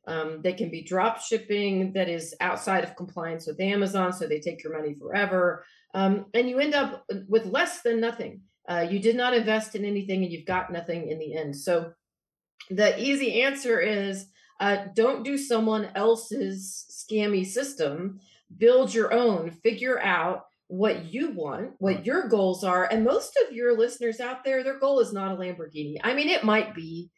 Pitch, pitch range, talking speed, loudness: 205 Hz, 180-235 Hz, 185 wpm, -26 LUFS